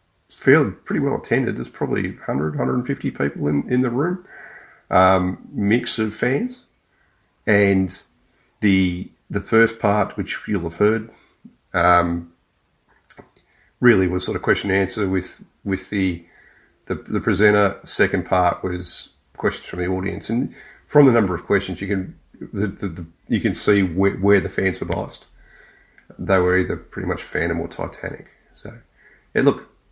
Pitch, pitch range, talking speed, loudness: 95 Hz, 90-105 Hz, 160 wpm, -21 LUFS